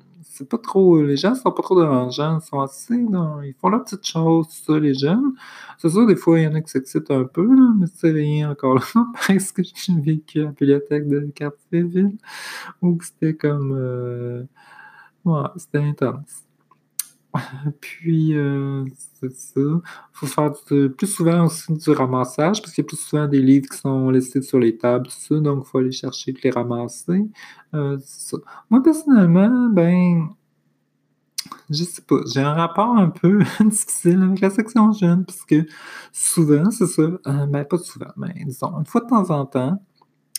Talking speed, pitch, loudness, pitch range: 195 wpm, 155 Hz, -19 LUFS, 140-185 Hz